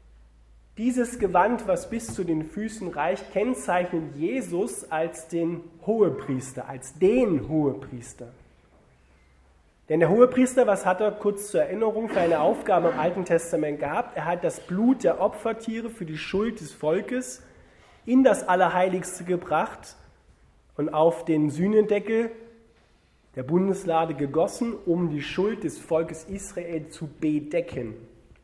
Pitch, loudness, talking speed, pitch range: 175 Hz, -25 LUFS, 130 wpm, 150-210 Hz